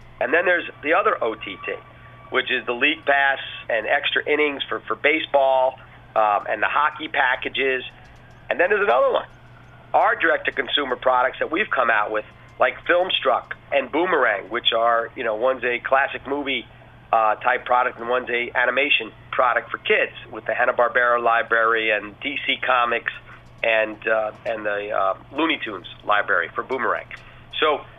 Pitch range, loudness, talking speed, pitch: 115-135 Hz, -21 LUFS, 165 wpm, 125 Hz